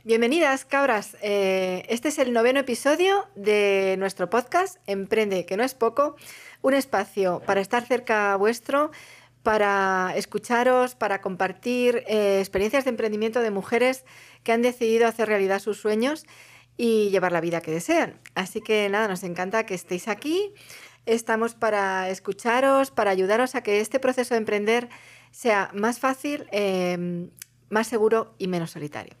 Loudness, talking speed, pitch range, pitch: -24 LUFS, 150 wpm, 195-245 Hz, 220 Hz